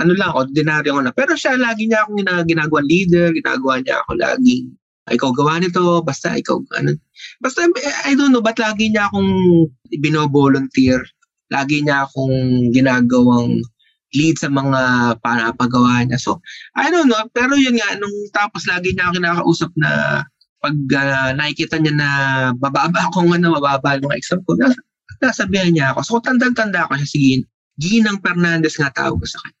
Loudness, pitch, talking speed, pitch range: -16 LUFS, 160 Hz, 170 wpm, 135-205 Hz